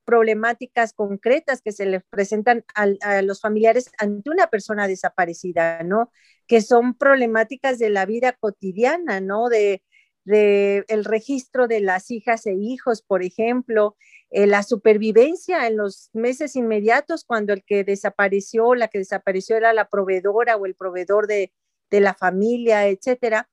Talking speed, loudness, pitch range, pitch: 150 wpm, -20 LUFS, 200-235 Hz, 215 Hz